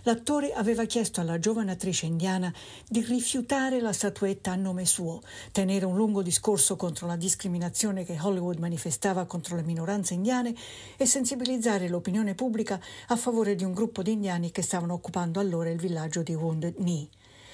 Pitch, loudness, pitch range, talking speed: 190 Hz, -28 LUFS, 175-220 Hz, 165 wpm